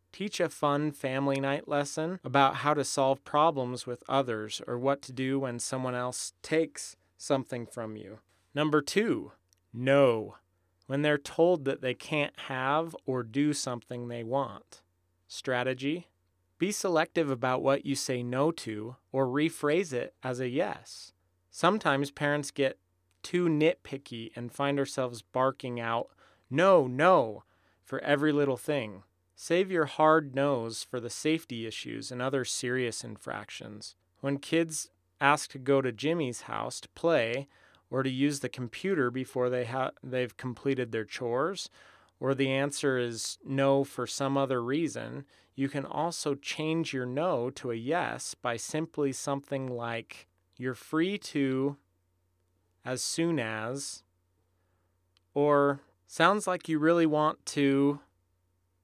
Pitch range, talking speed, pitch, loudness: 115-145 Hz, 140 wpm, 130 Hz, -30 LUFS